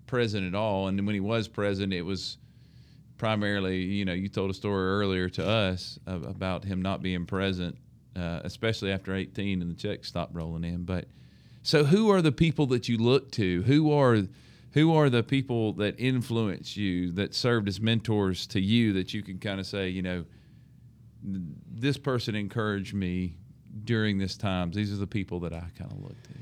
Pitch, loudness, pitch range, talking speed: 100 Hz, -28 LUFS, 95-120 Hz, 195 wpm